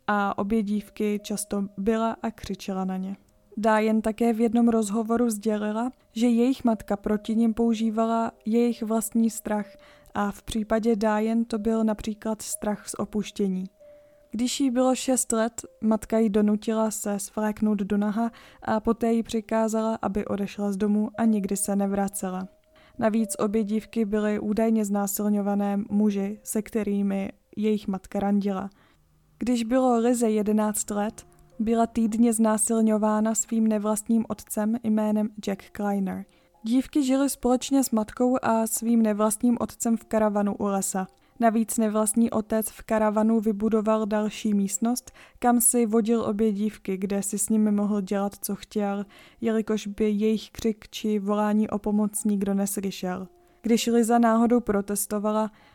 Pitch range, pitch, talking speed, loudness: 205-230 Hz, 220 Hz, 140 wpm, -25 LUFS